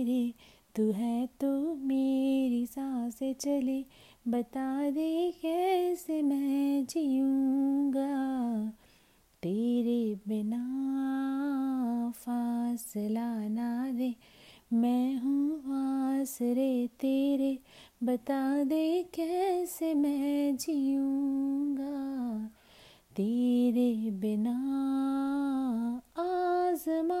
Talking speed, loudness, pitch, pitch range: 65 wpm, -31 LUFS, 270 Hz, 240-280 Hz